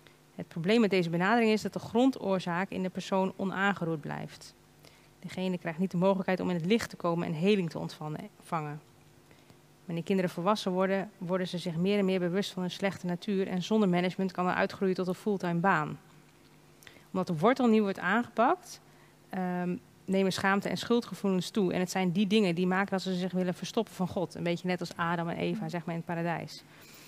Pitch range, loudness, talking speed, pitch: 175-195 Hz, -30 LUFS, 200 wpm, 185 Hz